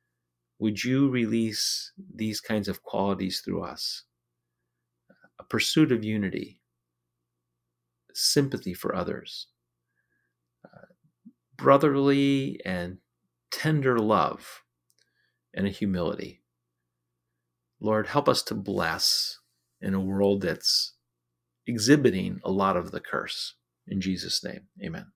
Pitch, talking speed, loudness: 90 Hz, 105 wpm, -26 LUFS